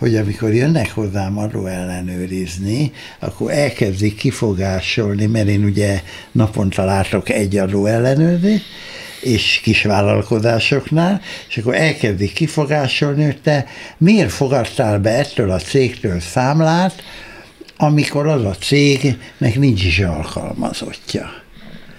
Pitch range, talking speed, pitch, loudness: 100-145 Hz, 105 wpm, 115 Hz, -16 LUFS